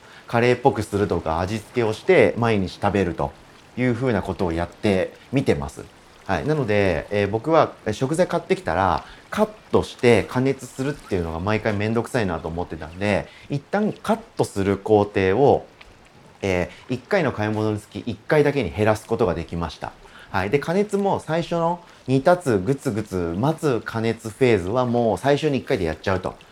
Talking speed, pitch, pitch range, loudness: 360 characters per minute, 110 Hz, 100-140 Hz, -22 LUFS